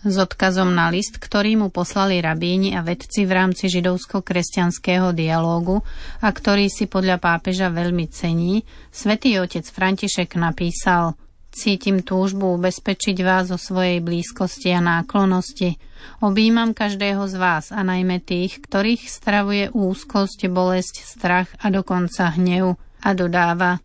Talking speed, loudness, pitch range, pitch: 130 wpm, -20 LUFS, 180-200 Hz, 185 Hz